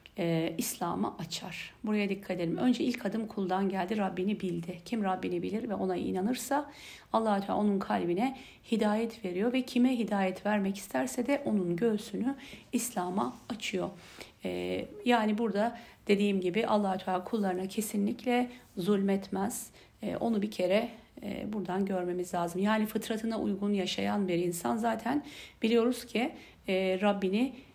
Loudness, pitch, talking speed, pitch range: -32 LUFS, 205 Hz, 140 wpm, 185-235 Hz